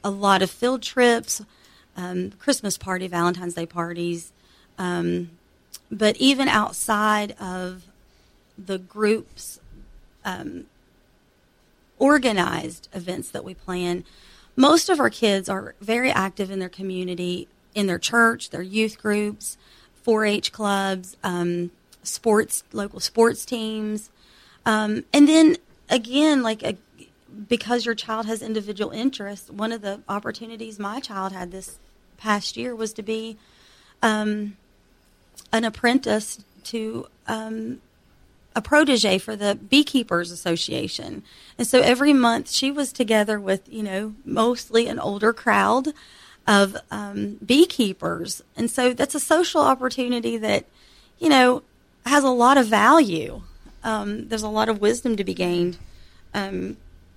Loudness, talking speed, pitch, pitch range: -22 LUFS, 130 wpm, 215 Hz, 190-240 Hz